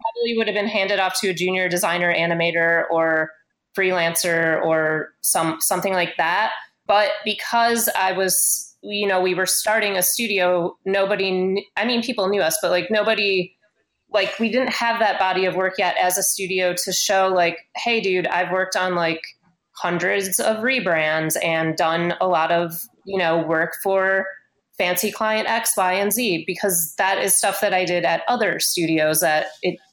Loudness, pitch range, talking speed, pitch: -20 LUFS, 170-205 Hz, 180 wpm, 185 Hz